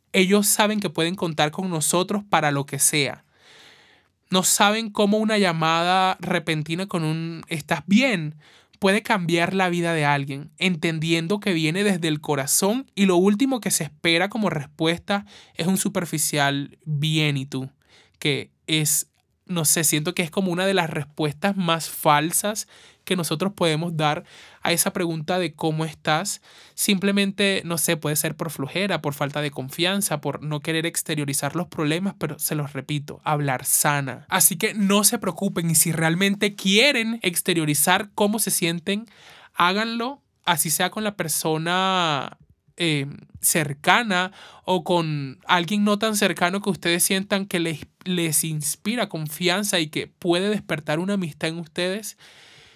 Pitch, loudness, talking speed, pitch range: 175 Hz, -22 LUFS, 155 wpm, 155-195 Hz